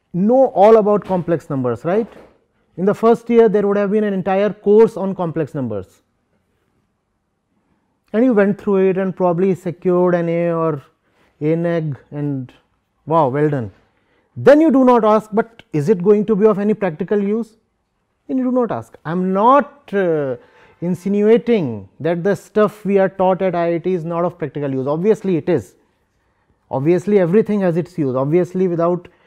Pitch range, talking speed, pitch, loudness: 160-210 Hz, 175 wpm, 185 Hz, -17 LUFS